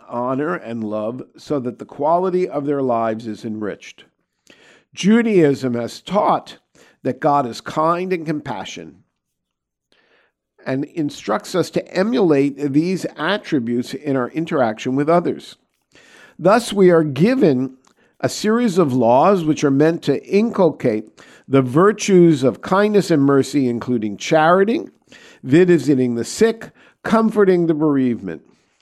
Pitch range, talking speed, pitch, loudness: 125-180 Hz, 125 wpm, 150 Hz, -18 LUFS